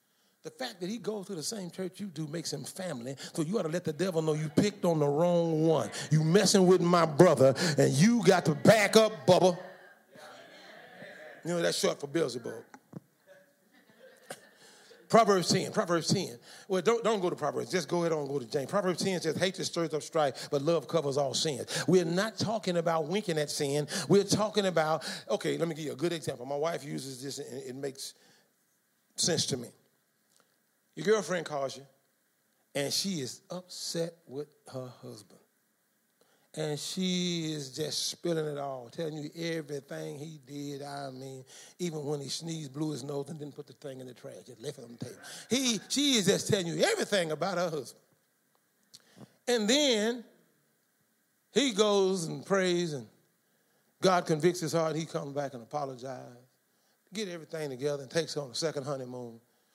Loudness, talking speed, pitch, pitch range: -30 LUFS, 185 wpm, 165 Hz, 145-185 Hz